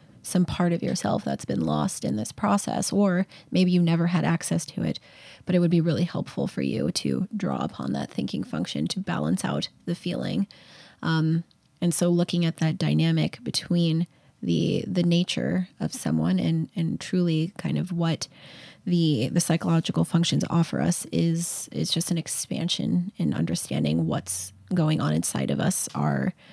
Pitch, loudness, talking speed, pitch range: 170 Hz, -26 LUFS, 170 wpm, 155-180 Hz